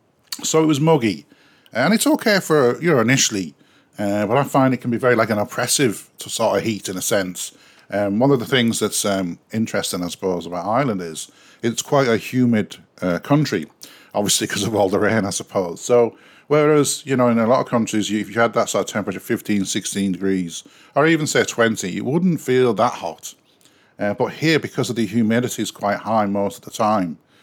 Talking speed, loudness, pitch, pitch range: 215 wpm, -19 LUFS, 115 Hz, 100-135 Hz